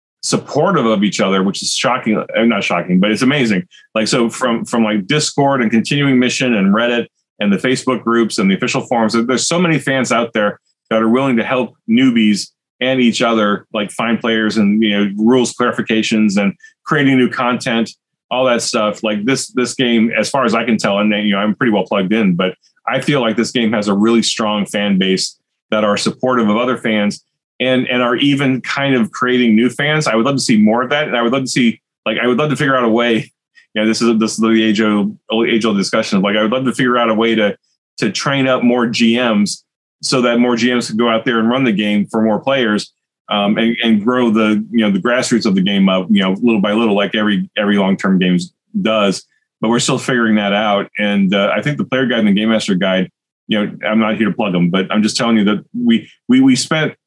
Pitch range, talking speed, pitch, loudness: 105-125 Hz, 245 wpm, 115 Hz, -14 LUFS